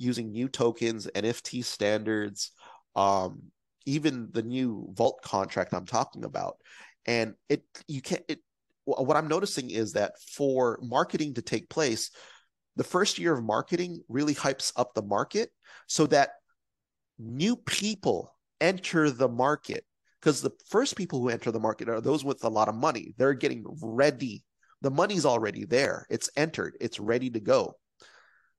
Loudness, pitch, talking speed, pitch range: -29 LUFS, 130 Hz, 155 wpm, 115-155 Hz